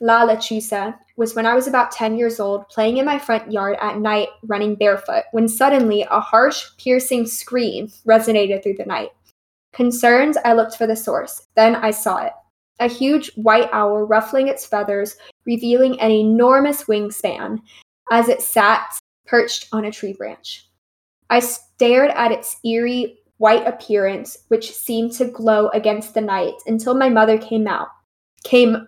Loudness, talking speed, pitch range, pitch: -17 LUFS, 165 wpm, 215-245 Hz, 225 Hz